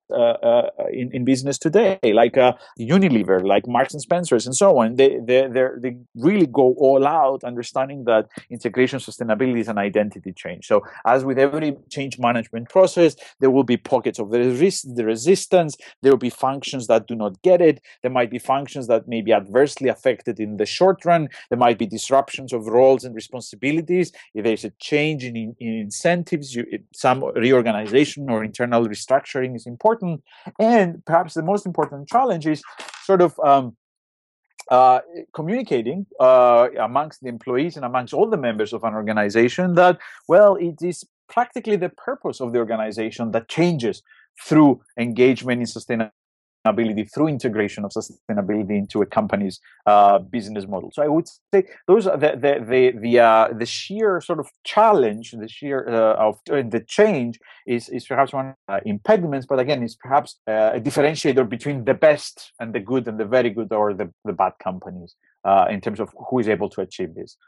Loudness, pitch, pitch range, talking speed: -20 LUFS, 130 Hz, 115-150 Hz, 180 wpm